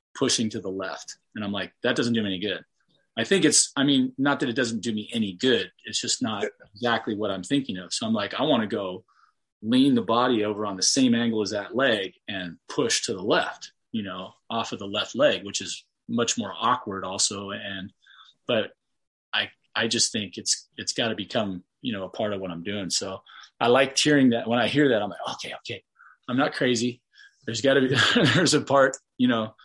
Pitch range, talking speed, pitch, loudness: 105-135 Hz, 230 wpm, 120 Hz, -25 LUFS